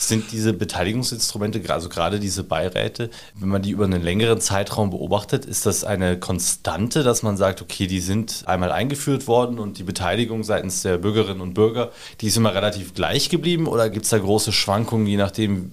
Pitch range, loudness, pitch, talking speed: 95-115 Hz, -21 LUFS, 105 Hz, 190 wpm